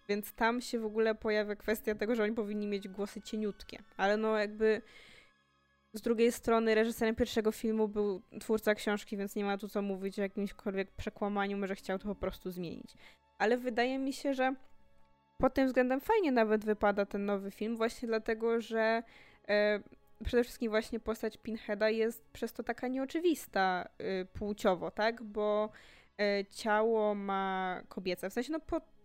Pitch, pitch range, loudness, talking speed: 215 Hz, 205-230 Hz, -34 LUFS, 165 wpm